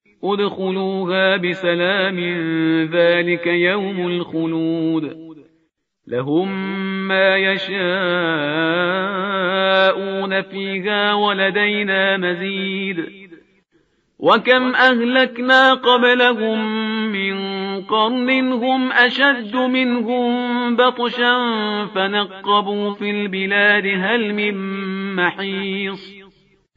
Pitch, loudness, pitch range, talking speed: 195 Hz, -17 LUFS, 185-220 Hz, 60 wpm